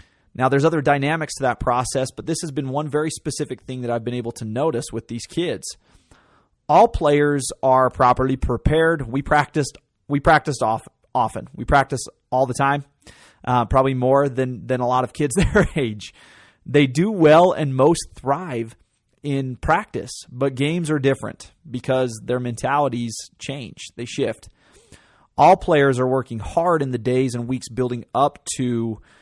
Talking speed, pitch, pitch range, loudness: 170 wpm, 130 Hz, 125-150 Hz, -20 LUFS